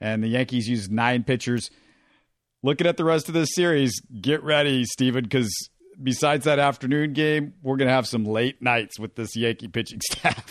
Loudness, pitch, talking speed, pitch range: -23 LUFS, 130 Hz, 190 wpm, 115-150 Hz